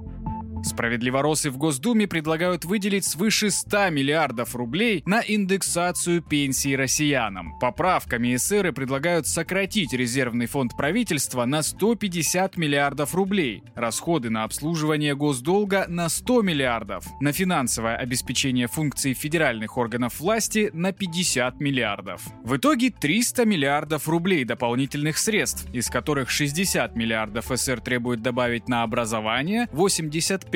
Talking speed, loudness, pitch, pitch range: 115 wpm, -23 LUFS, 150 Hz, 125-185 Hz